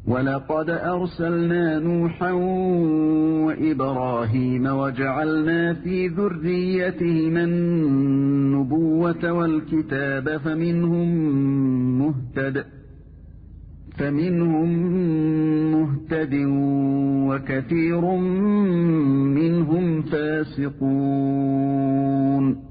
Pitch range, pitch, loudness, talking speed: 135-170 Hz, 155 Hz, -22 LUFS, 40 wpm